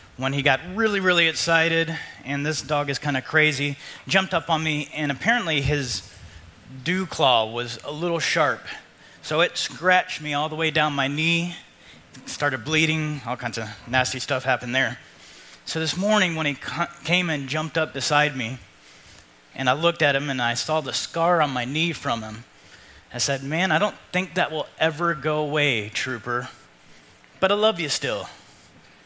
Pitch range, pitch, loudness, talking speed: 130-165 Hz, 150 Hz, -23 LUFS, 185 wpm